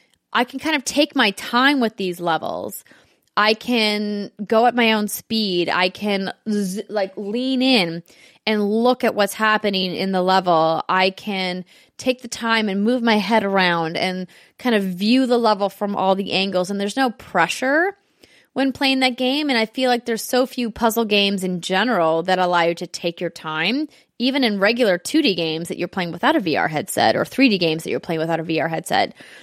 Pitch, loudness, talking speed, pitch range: 210 Hz, -19 LUFS, 200 wpm, 185-245 Hz